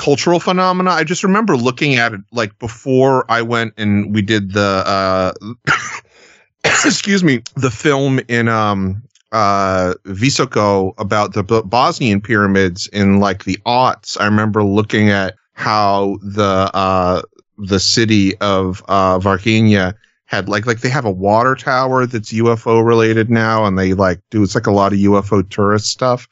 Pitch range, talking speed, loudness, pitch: 100-120 Hz, 160 wpm, -14 LUFS, 105 Hz